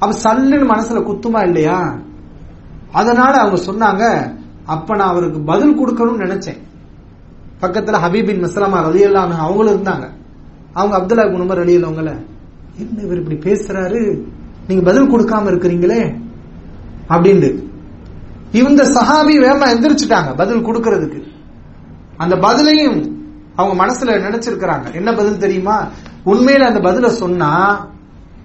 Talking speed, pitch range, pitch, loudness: 110 wpm, 175-225 Hz, 195 Hz, -13 LUFS